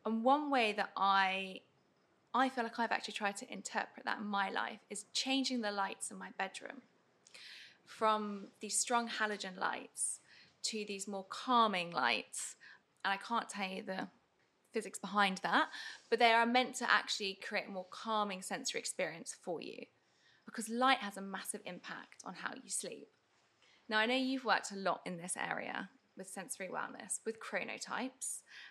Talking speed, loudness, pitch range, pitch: 170 wpm, -37 LUFS, 195-235 Hz, 215 Hz